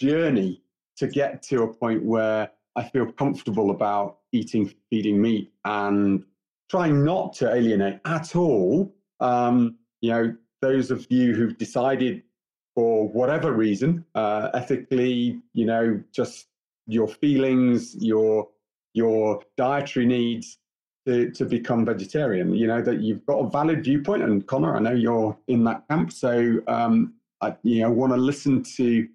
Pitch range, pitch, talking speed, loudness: 110-130 Hz, 115 Hz, 150 wpm, -23 LUFS